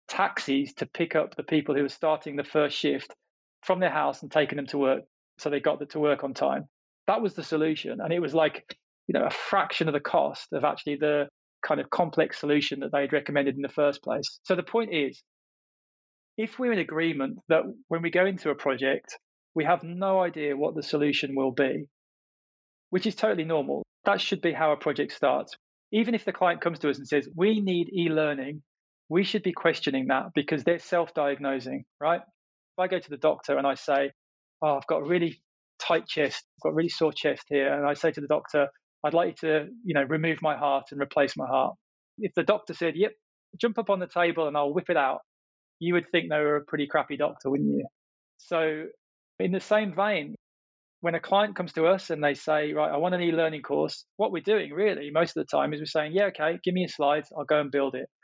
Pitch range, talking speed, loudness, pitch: 145-180 Hz, 235 wpm, -27 LUFS, 155 Hz